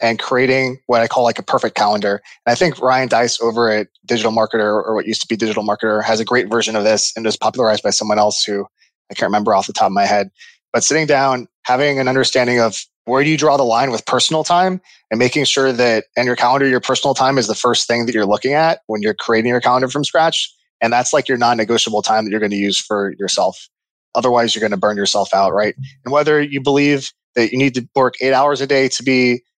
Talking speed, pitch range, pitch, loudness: 250 wpm, 110-135 Hz, 120 Hz, -16 LUFS